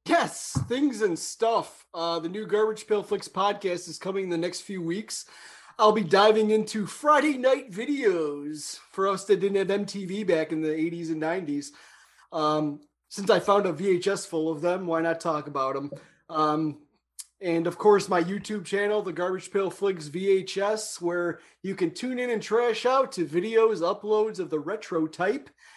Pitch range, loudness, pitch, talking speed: 165-215 Hz, -26 LUFS, 190 Hz, 180 wpm